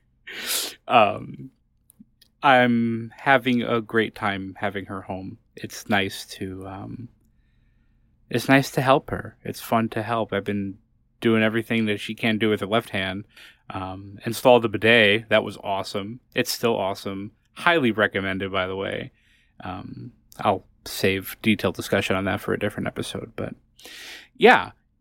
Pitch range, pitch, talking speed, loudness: 100-115 Hz, 110 Hz, 150 wpm, -23 LUFS